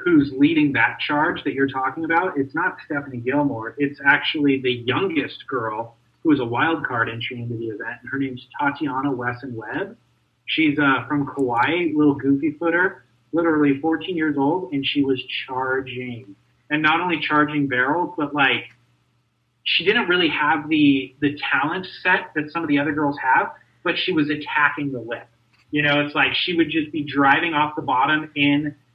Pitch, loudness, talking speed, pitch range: 145 Hz, -21 LUFS, 180 wpm, 130-155 Hz